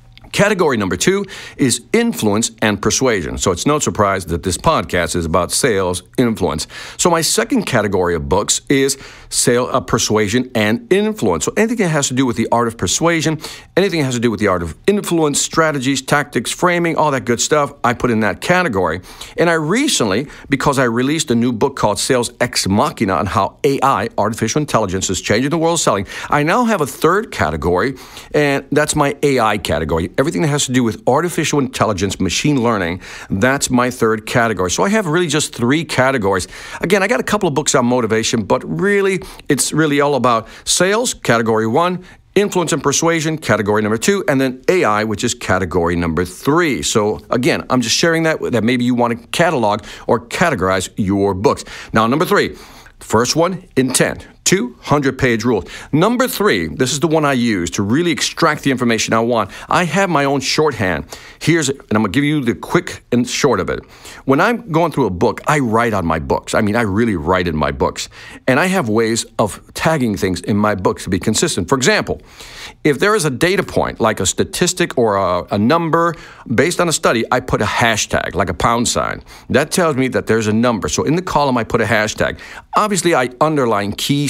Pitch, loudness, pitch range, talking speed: 130 Hz, -16 LUFS, 110-155 Hz, 205 wpm